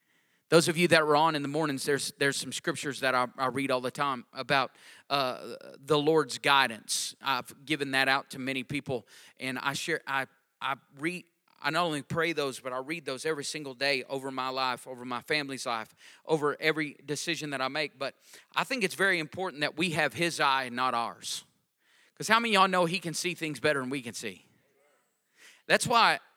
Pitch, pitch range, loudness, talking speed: 145 Hz, 130-160 Hz, -29 LUFS, 215 wpm